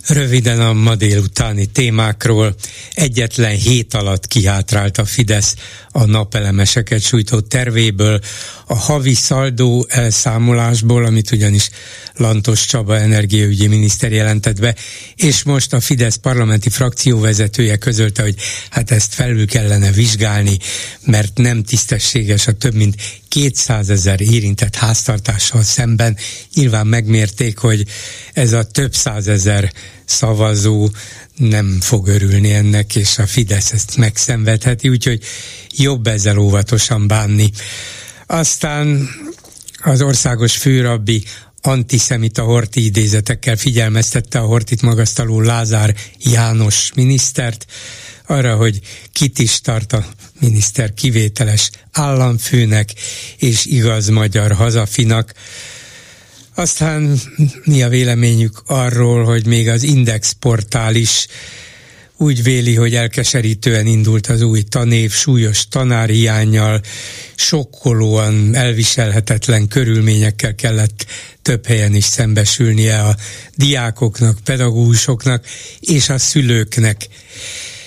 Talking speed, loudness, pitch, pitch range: 105 wpm, -13 LUFS, 115 Hz, 105-125 Hz